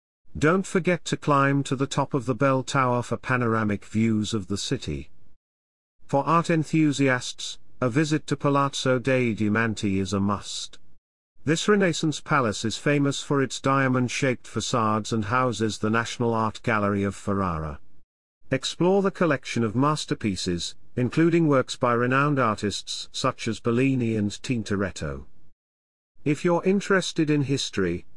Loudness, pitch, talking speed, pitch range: -24 LUFS, 125 Hz, 145 wpm, 100-145 Hz